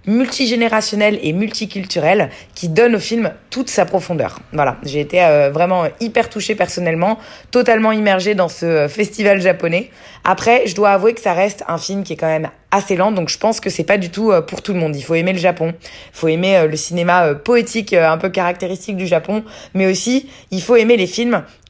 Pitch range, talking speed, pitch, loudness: 170-220 Hz, 200 wpm, 190 Hz, -16 LUFS